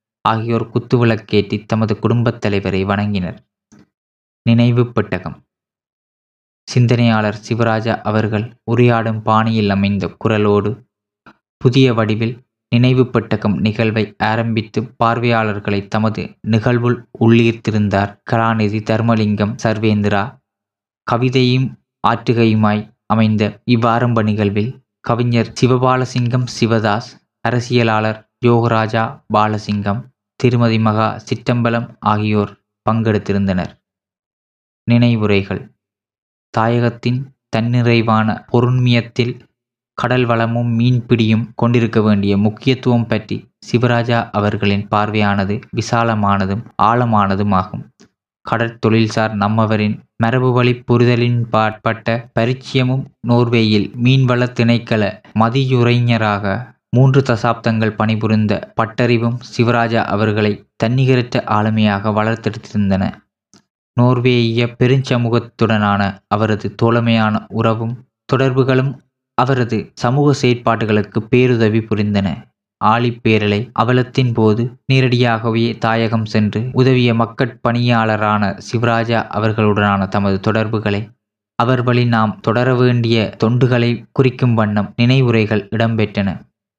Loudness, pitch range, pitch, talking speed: -16 LUFS, 105-120 Hz, 115 Hz, 75 wpm